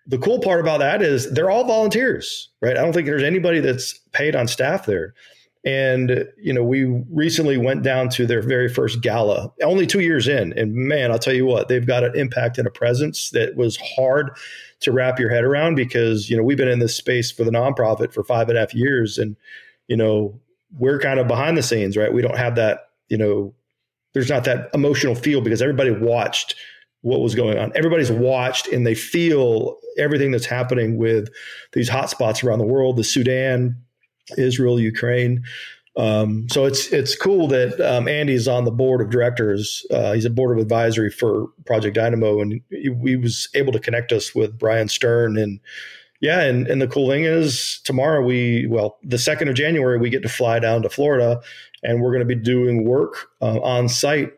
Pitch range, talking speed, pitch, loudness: 115-135 Hz, 205 wpm, 125 Hz, -19 LUFS